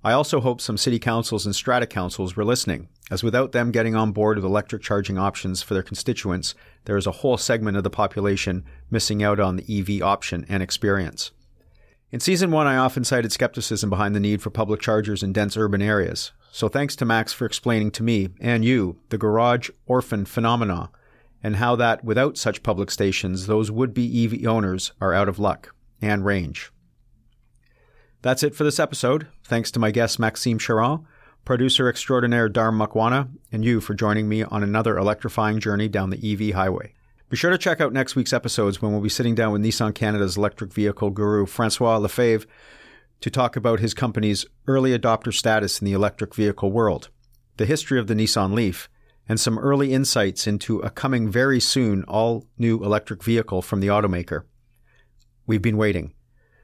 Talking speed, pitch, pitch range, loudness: 185 wpm, 110 Hz, 100-120 Hz, -22 LUFS